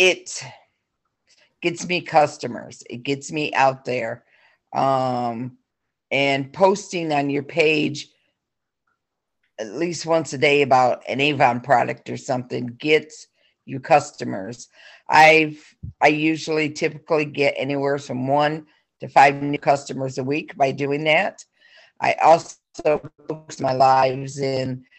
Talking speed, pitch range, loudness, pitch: 125 wpm, 135-155 Hz, -20 LUFS, 145 Hz